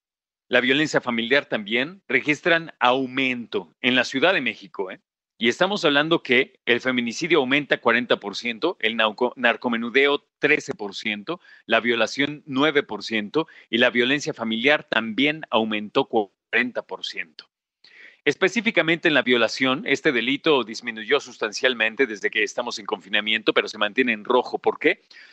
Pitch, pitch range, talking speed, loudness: 125 Hz, 115-145 Hz, 125 wpm, -22 LUFS